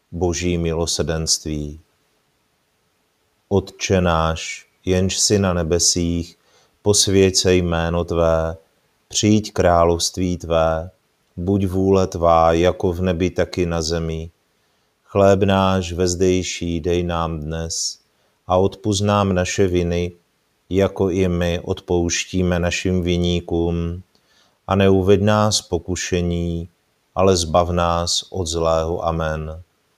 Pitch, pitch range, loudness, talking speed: 85 Hz, 85-95 Hz, -19 LUFS, 105 wpm